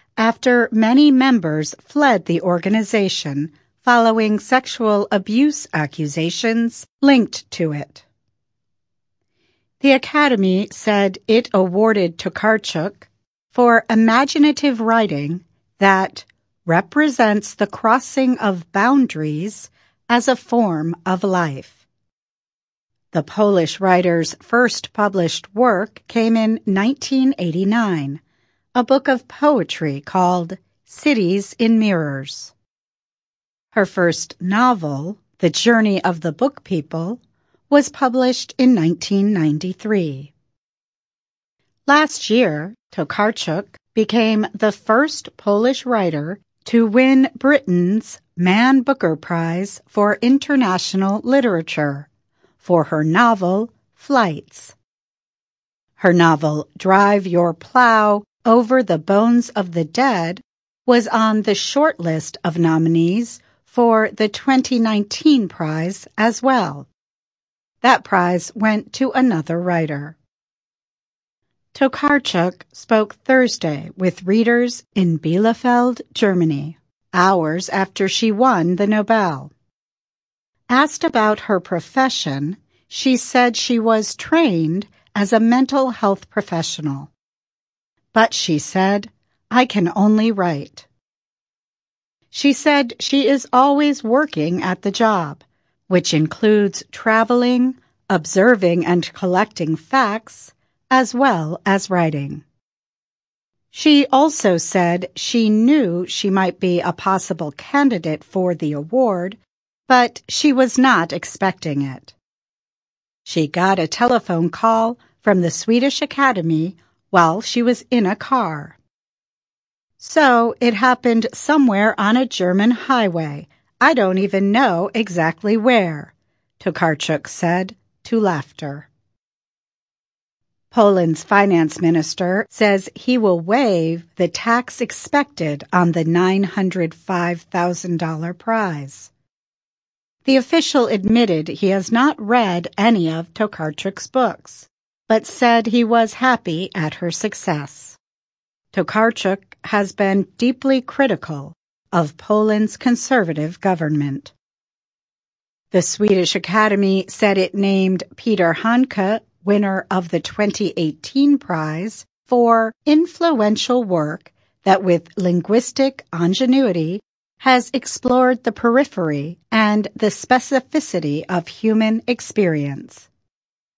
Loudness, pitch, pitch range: -17 LUFS, 200 Hz, 170-240 Hz